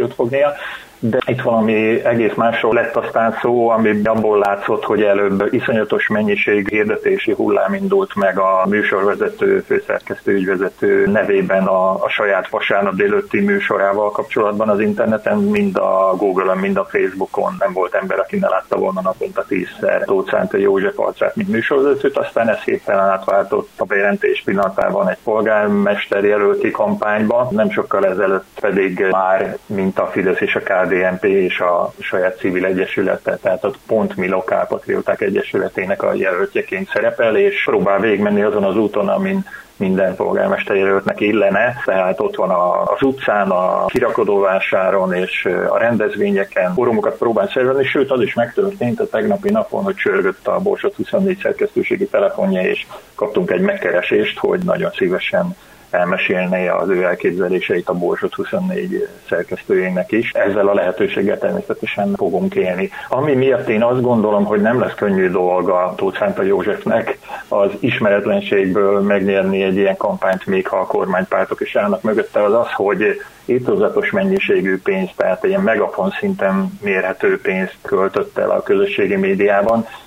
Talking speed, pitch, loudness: 150 wpm, 145 Hz, -16 LUFS